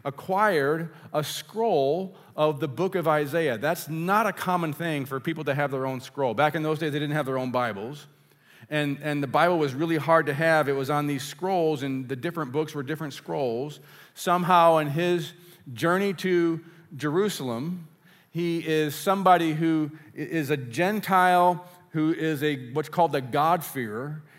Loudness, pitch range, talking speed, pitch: -25 LUFS, 150-175 Hz, 175 wpm, 155 Hz